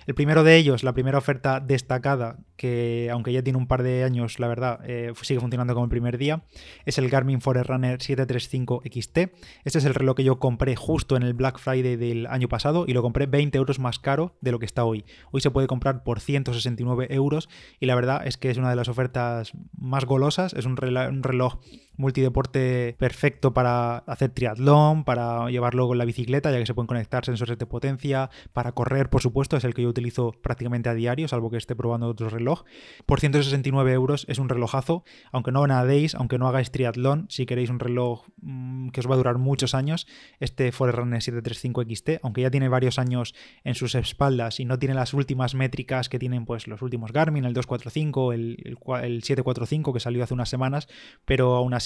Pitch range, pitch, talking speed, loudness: 120-135 Hz, 130 Hz, 205 wpm, -25 LUFS